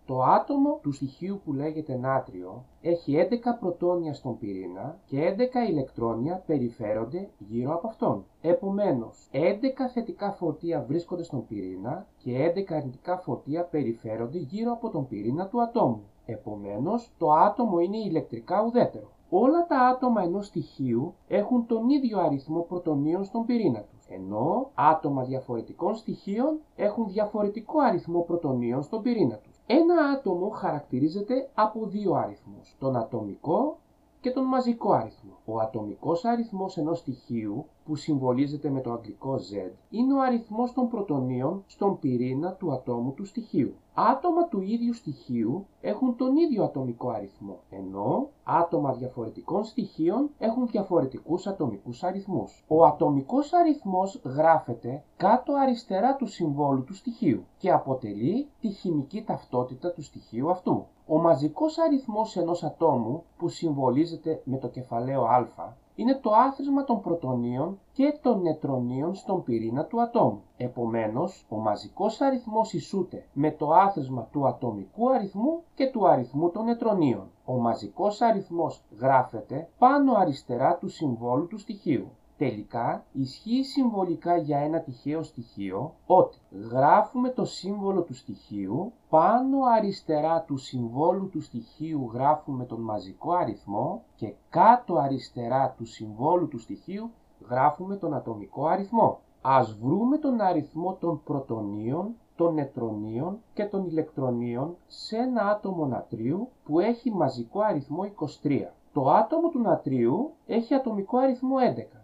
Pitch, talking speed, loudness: 165 Hz, 130 wpm, -27 LUFS